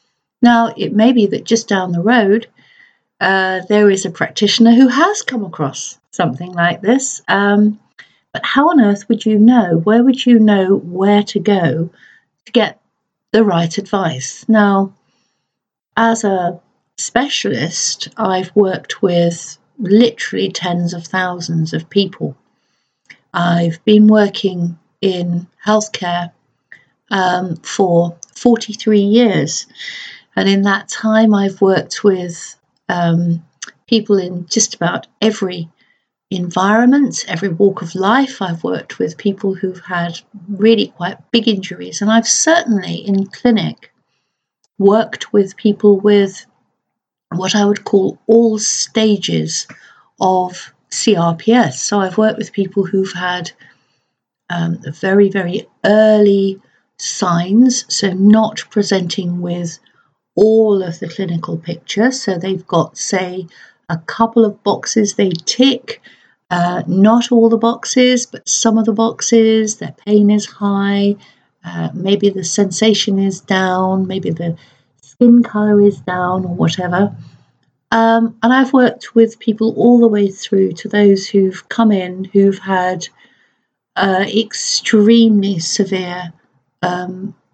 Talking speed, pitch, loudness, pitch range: 130 wpm, 200 Hz, -14 LUFS, 180-220 Hz